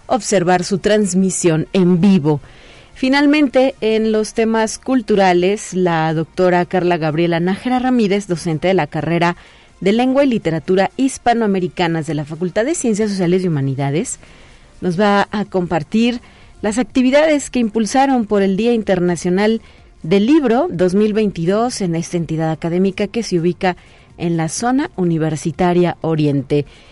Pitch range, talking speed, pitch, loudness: 170-220 Hz, 135 wpm, 190 Hz, -16 LUFS